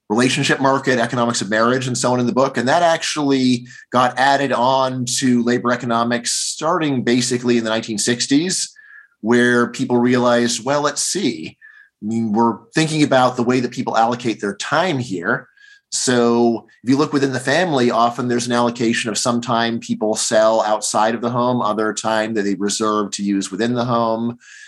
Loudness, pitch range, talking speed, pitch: -18 LUFS, 115-130 Hz, 180 wpm, 120 Hz